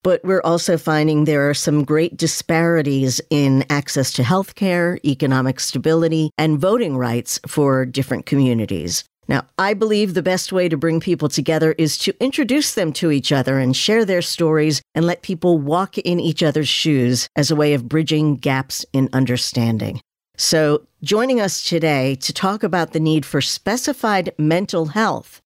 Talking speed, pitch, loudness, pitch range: 165 wpm, 155 Hz, -18 LUFS, 140-175 Hz